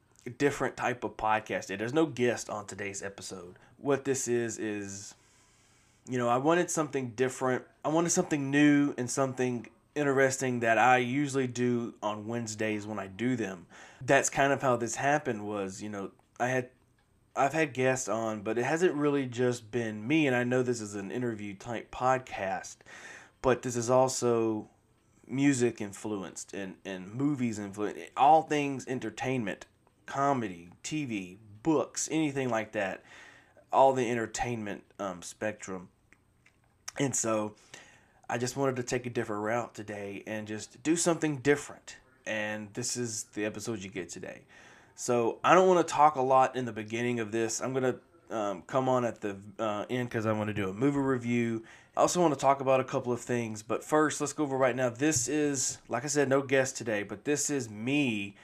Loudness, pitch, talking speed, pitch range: -30 LUFS, 120 Hz, 180 wpm, 110-135 Hz